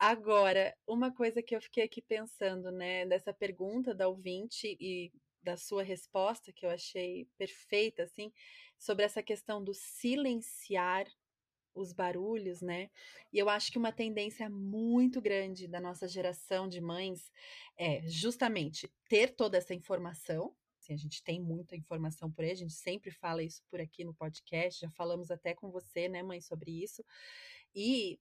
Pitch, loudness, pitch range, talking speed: 190 Hz, -37 LUFS, 175-220 Hz, 160 wpm